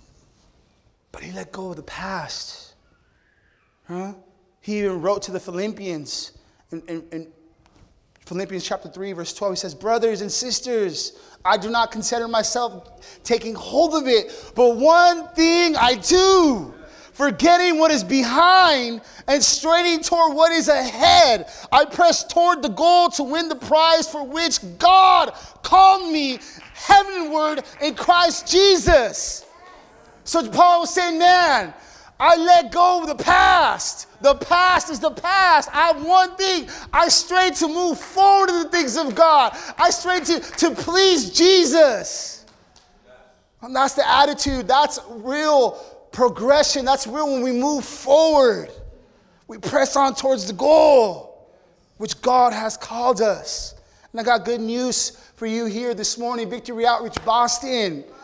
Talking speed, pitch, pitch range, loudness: 145 wpm, 290 Hz, 235-345 Hz, -17 LUFS